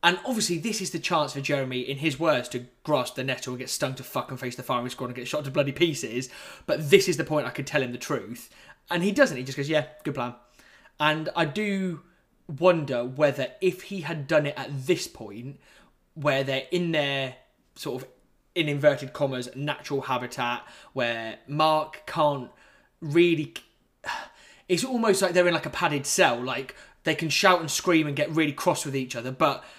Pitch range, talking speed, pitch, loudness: 130-170 Hz, 205 wpm, 150 Hz, -26 LUFS